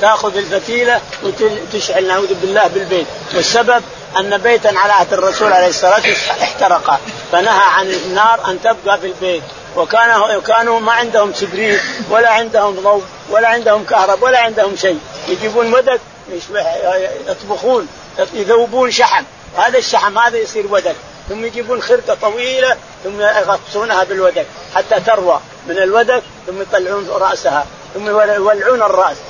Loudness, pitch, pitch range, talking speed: -13 LUFS, 210 Hz, 190-235 Hz, 130 wpm